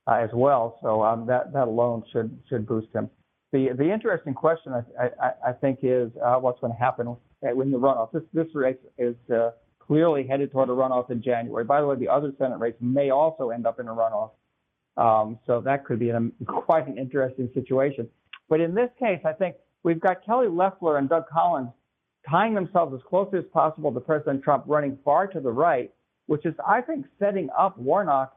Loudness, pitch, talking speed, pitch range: -25 LUFS, 135 Hz, 210 wpm, 120-160 Hz